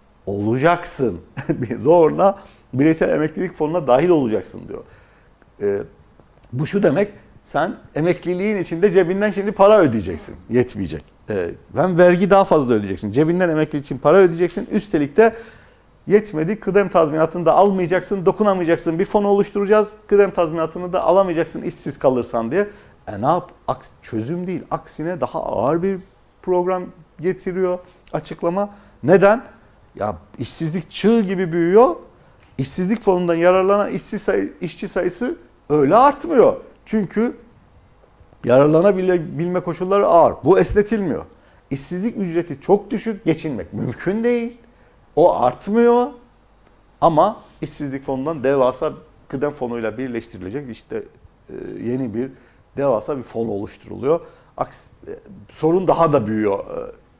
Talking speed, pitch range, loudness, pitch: 115 wpm, 140-200 Hz, -19 LUFS, 180 Hz